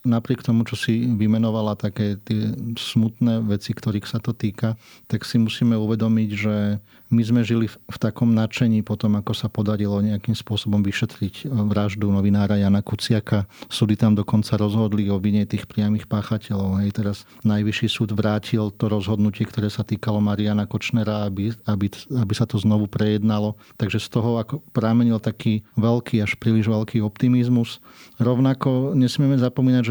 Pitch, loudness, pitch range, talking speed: 110 Hz, -22 LUFS, 105-115 Hz, 155 wpm